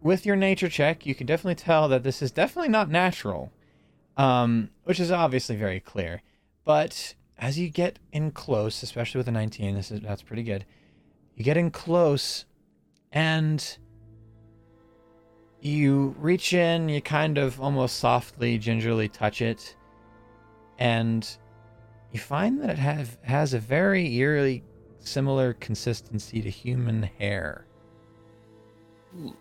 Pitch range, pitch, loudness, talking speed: 110-155 Hz, 125 Hz, -26 LUFS, 135 wpm